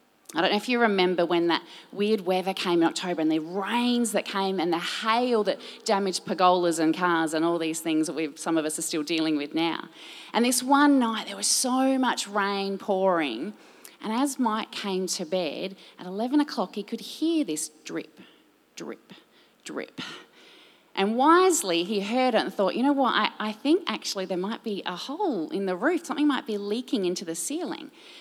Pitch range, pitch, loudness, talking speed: 175-240 Hz, 200 Hz, -26 LUFS, 200 wpm